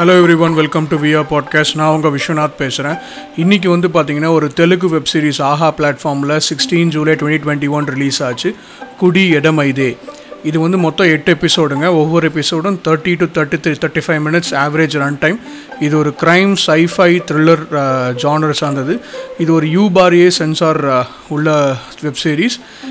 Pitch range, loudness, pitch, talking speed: 150-175 Hz, -13 LUFS, 155 Hz, 160 wpm